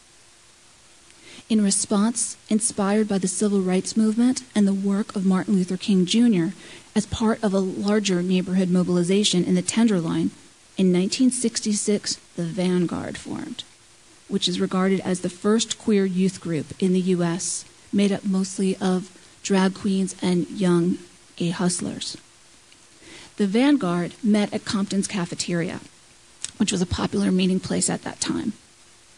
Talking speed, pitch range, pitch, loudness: 140 wpm, 180-210 Hz, 190 Hz, -23 LUFS